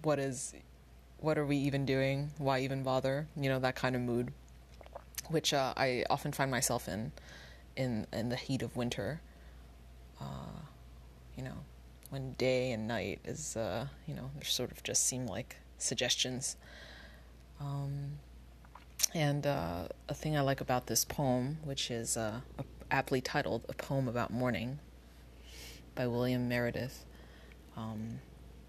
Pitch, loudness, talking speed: 120 Hz, -35 LUFS, 145 wpm